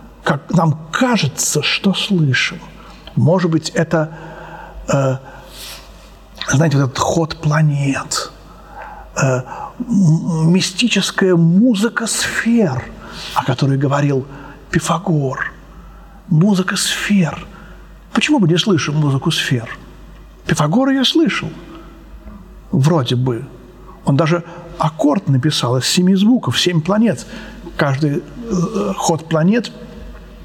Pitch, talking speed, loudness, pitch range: 170 Hz, 95 wpm, -16 LUFS, 145-195 Hz